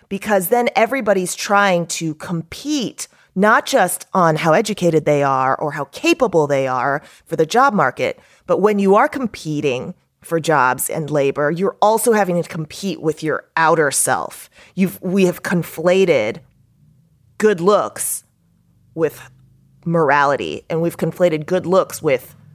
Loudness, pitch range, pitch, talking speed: -17 LUFS, 150-200 Hz, 170 Hz, 140 wpm